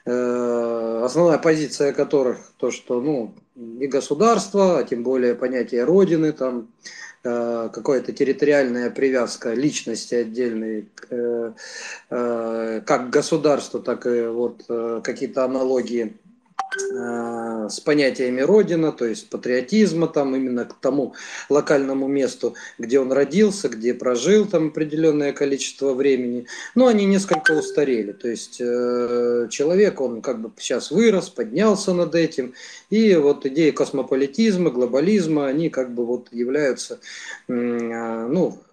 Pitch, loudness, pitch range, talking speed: 135 Hz, -21 LUFS, 120-165 Hz, 115 wpm